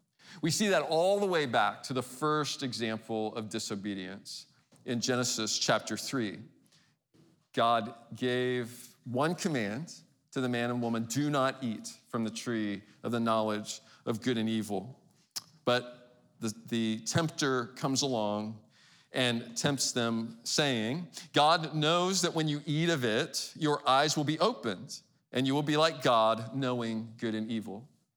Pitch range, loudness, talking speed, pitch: 115-150 Hz, -31 LUFS, 155 wpm, 125 Hz